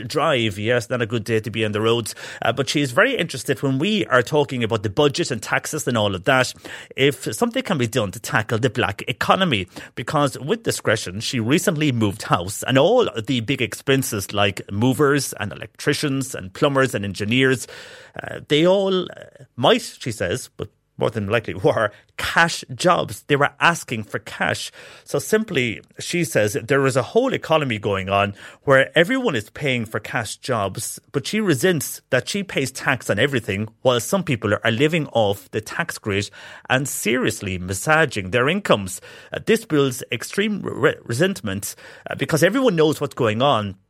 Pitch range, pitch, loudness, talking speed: 115-155 Hz, 130 Hz, -21 LUFS, 180 wpm